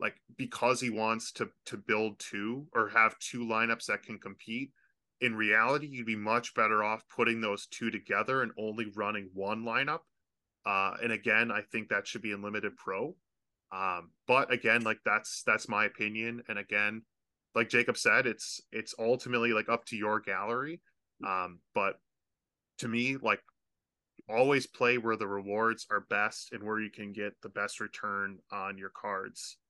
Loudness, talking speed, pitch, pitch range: -32 LUFS, 175 wpm, 110 Hz, 105-120 Hz